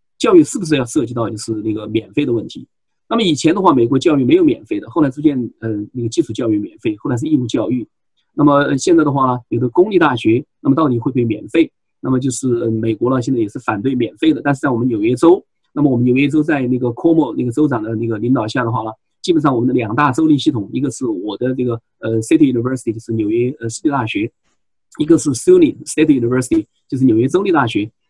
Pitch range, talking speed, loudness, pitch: 115-160 Hz, 435 characters per minute, -16 LUFS, 130 Hz